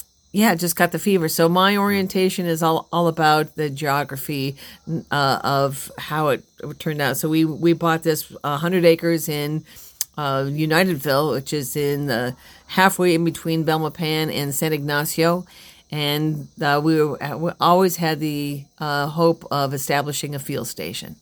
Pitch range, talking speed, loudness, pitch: 145-170 Hz, 160 wpm, -21 LUFS, 155 Hz